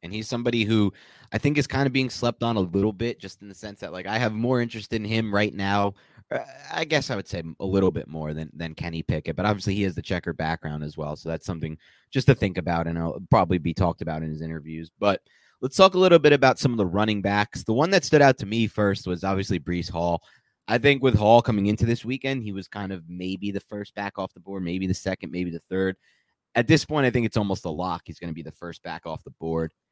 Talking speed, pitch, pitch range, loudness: 270 wpm, 100 Hz, 85-115 Hz, -24 LUFS